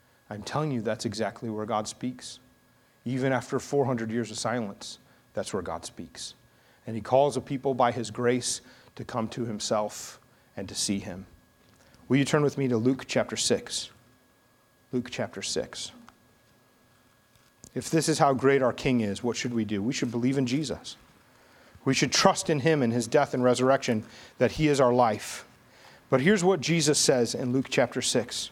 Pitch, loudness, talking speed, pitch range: 125 Hz, -27 LUFS, 185 wpm, 115-135 Hz